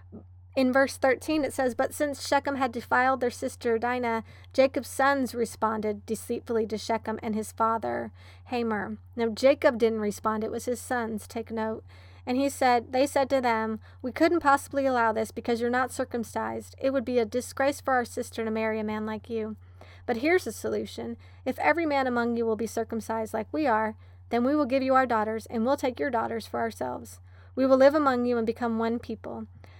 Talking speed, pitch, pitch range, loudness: 205 wpm, 230 Hz, 215-260 Hz, -27 LUFS